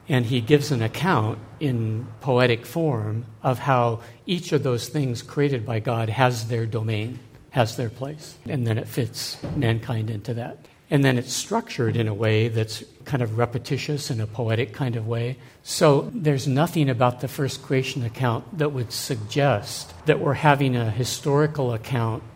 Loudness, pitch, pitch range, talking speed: -24 LUFS, 125 Hz, 115-140 Hz, 170 wpm